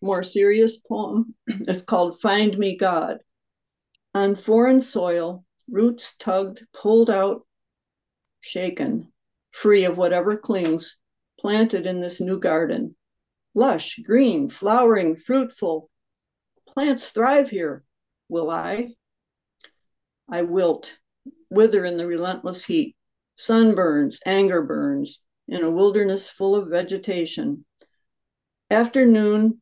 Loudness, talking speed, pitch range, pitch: -21 LUFS, 105 wpm, 185-230 Hz, 205 Hz